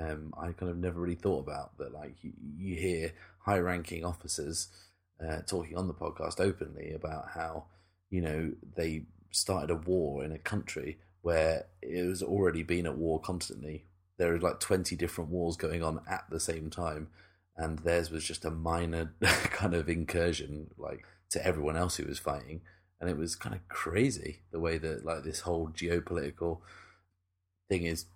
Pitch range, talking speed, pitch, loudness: 80-90 Hz, 180 wpm, 85 Hz, -34 LUFS